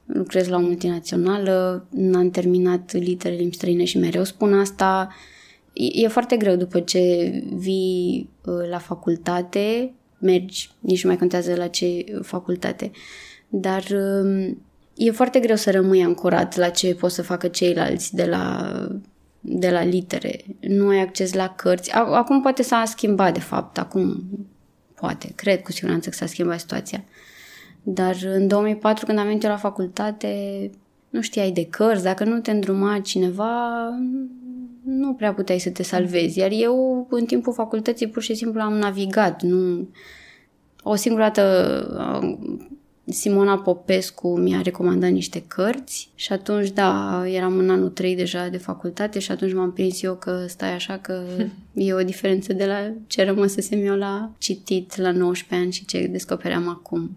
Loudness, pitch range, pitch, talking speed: -22 LUFS, 180-210 Hz, 190 Hz, 155 wpm